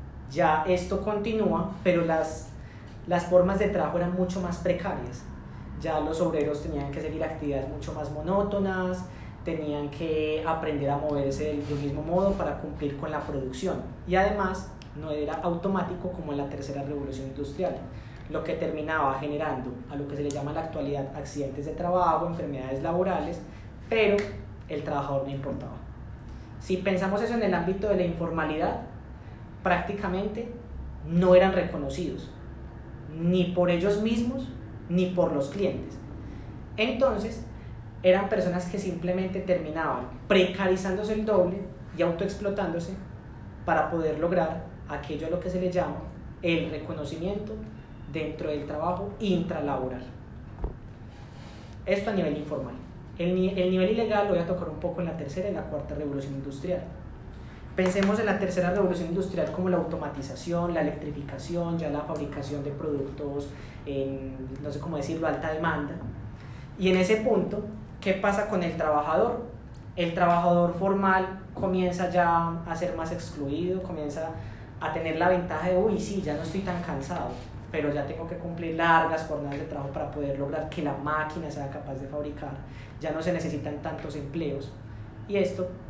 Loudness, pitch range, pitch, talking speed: -28 LUFS, 145-185 Hz, 160 Hz, 155 wpm